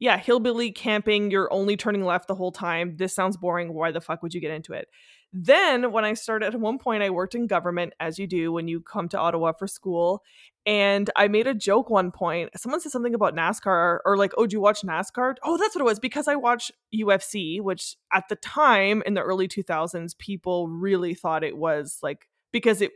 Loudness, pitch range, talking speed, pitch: -24 LUFS, 175-220 Hz, 225 wpm, 195 Hz